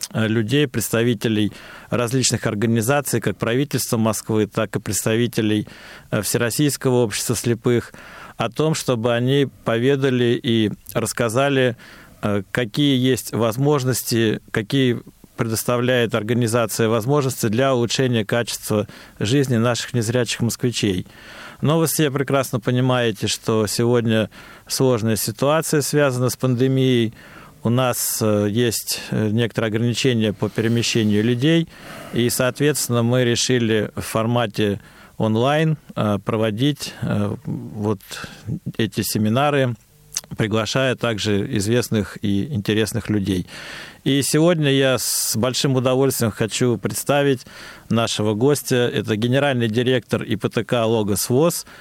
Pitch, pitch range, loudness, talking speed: 120 Hz, 110-130 Hz, -20 LUFS, 100 wpm